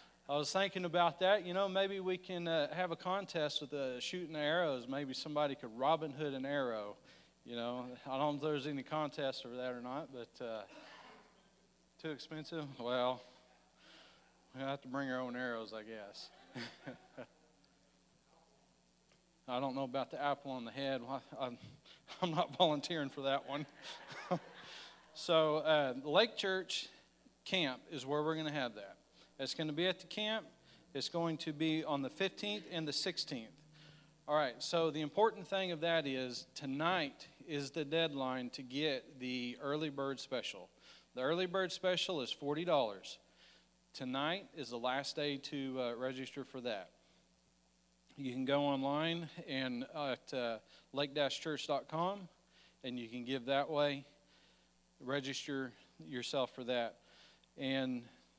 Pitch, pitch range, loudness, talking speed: 140 Hz, 130-160 Hz, -39 LUFS, 160 wpm